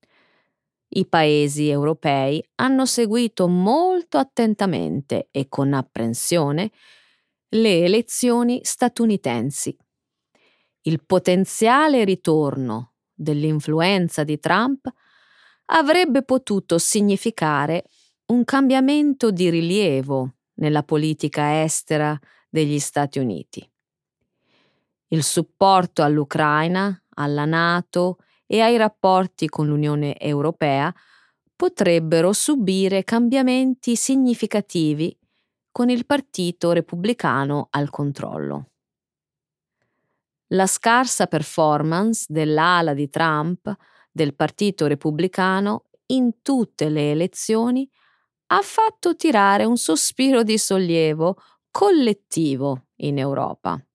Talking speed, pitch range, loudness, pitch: 85 wpm, 150-230 Hz, -20 LUFS, 180 Hz